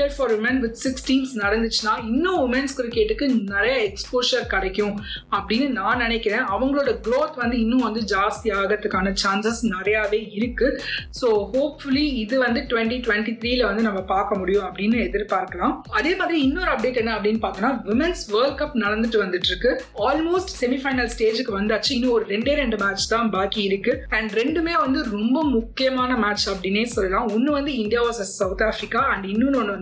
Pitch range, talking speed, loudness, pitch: 210-265 Hz, 125 wpm, -22 LUFS, 230 Hz